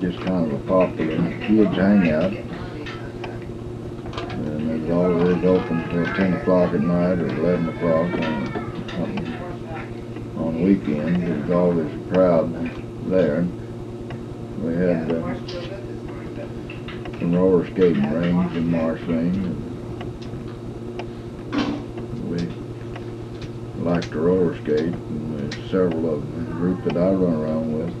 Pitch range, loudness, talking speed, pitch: 85-115 Hz, -23 LUFS, 115 wpm, 90 Hz